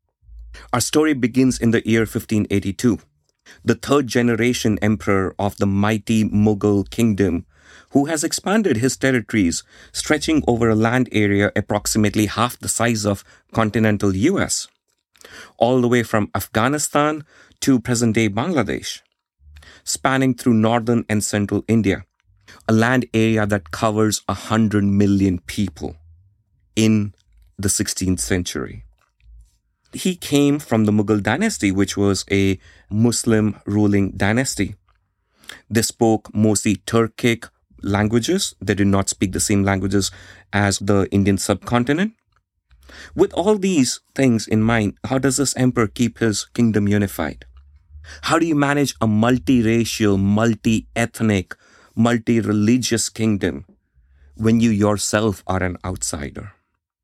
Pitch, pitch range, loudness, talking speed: 105 Hz, 100-115 Hz, -19 LUFS, 125 wpm